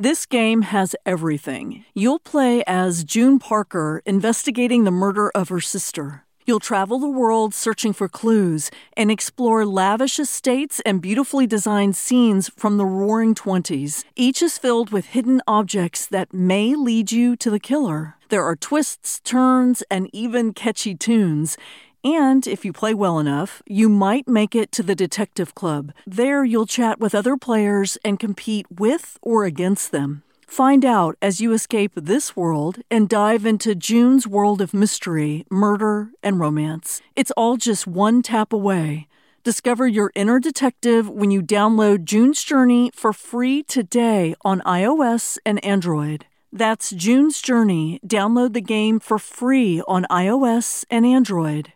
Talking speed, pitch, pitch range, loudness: 155 wpm, 215 Hz, 195-245 Hz, -19 LUFS